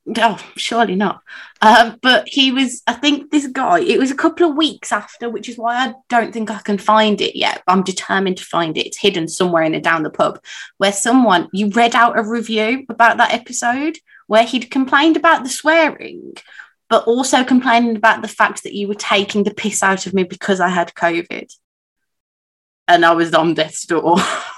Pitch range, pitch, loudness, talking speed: 195-255 Hz, 225 Hz, -15 LUFS, 205 wpm